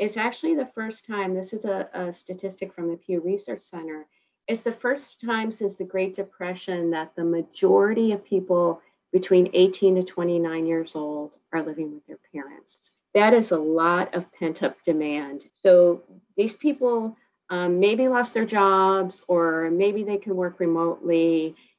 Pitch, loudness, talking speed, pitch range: 185 Hz, -24 LUFS, 170 wpm, 170-210 Hz